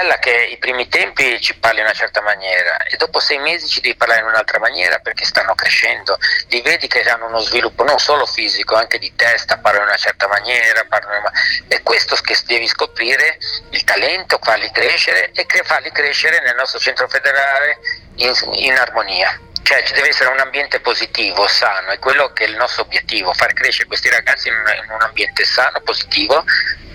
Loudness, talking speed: -14 LUFS, 185 wpm